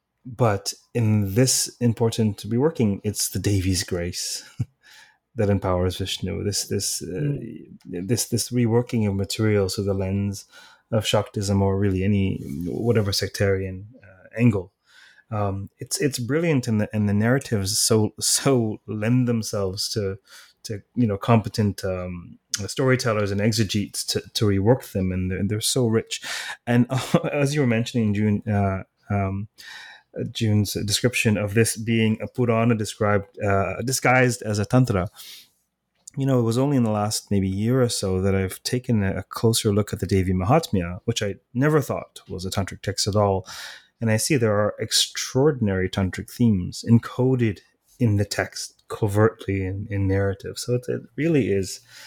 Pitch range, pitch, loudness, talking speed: 100-120 Hz, 105 Hz, -23 LUFS, 155 wpm